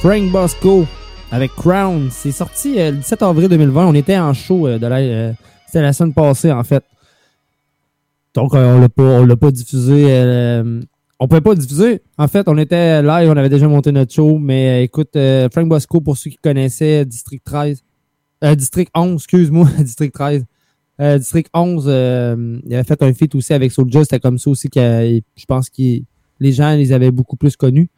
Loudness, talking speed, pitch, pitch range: -13 LUFS, 205 wpm, 145 Hz, 130-160 Hz